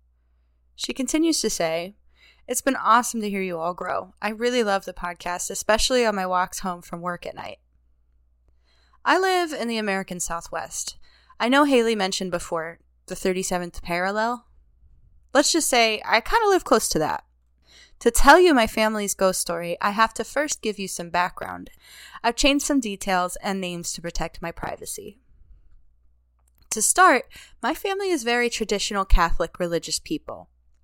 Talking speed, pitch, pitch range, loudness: 165 wpm, 190 Hz, 165-235 Hz, -23 LUFS